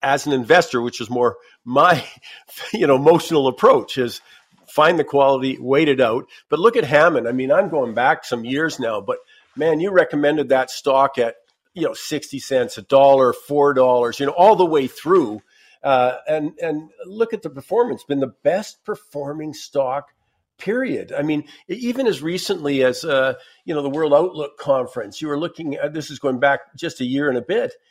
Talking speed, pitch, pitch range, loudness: 195 wpm, 145 Hz, 135-170 Hz, -19 LUFS